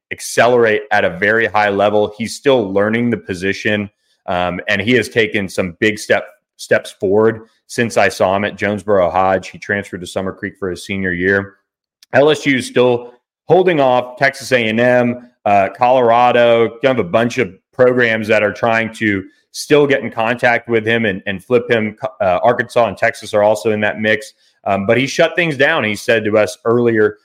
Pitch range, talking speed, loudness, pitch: 100-120 Hz, 190 wpm, -15 LUFS, 110 Hz